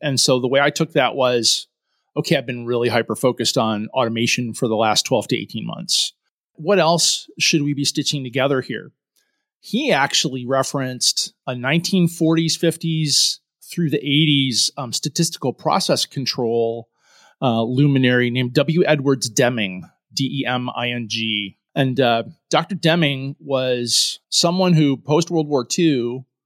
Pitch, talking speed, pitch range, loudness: 135 Hz, 150 wpm, 120-155 Hz, -19 LUFS